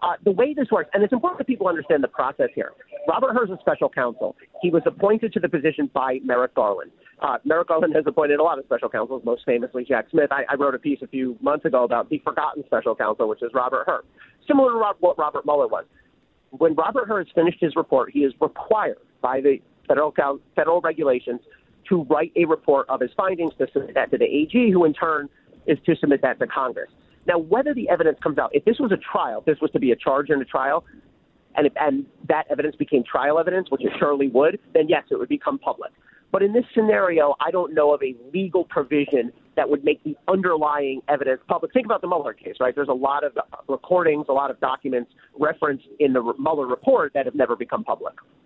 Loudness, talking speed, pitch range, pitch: -22 LUFS, 230 wpm, 140-215 Hz, 160 Hz